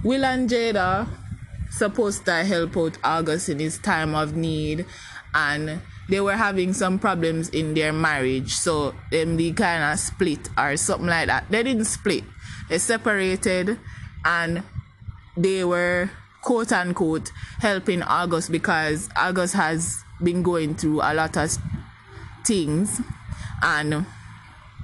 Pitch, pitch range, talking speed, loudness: 165 Hz, 155-195 Hz, 130 wpm, -23 LUFS